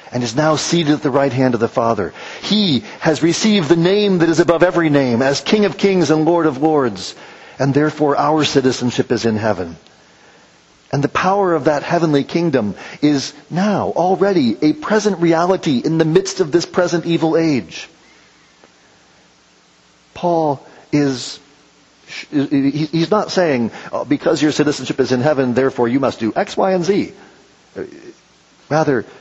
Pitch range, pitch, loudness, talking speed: 130-170 Hz, 150 Hz, -16 LUFS, 160 wpm